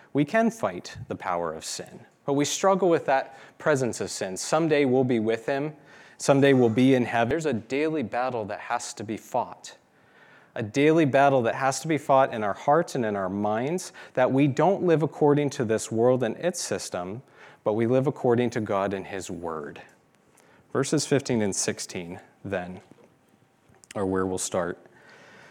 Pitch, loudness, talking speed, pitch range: 130 Hz, -25 LUFS, 185 wpm, 110-145 Hz